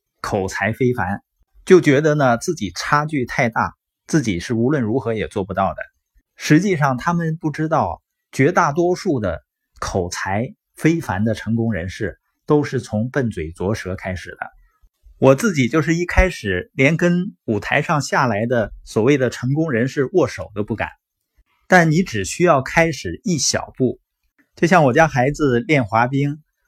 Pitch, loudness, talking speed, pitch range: 135 Hz, -19 LUFS, 235 characters per minute, 110-160 Hz